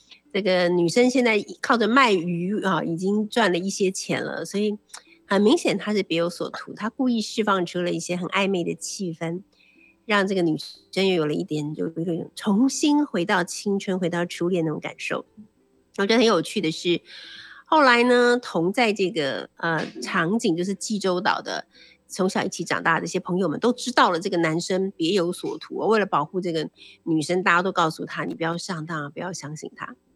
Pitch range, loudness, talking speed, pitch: 170-215 Hz, -23 LUFS, 285 characters per minute, 185 Hz